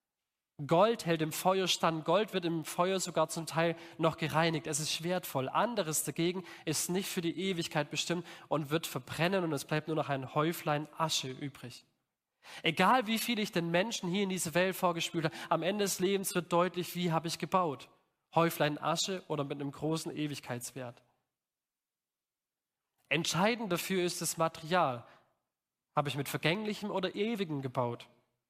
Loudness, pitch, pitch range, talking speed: -33 LUFS, 165 Hz, 150-180 Hz, 165 wpm